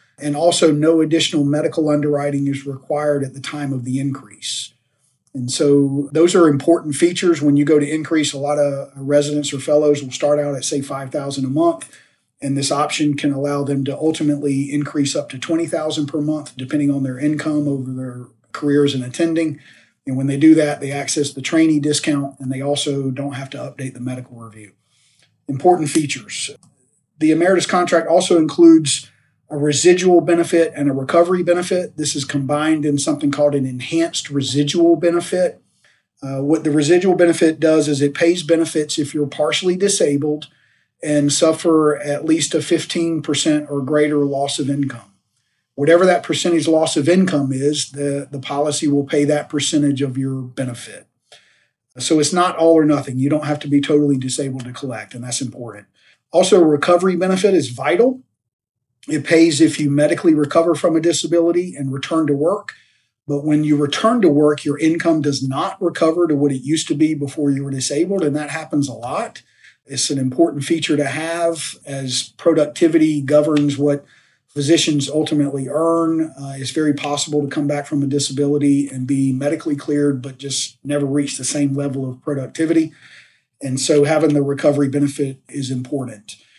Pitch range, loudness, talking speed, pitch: 140-160 Hz, -17 LUFS, 175 wpm, 145 Hz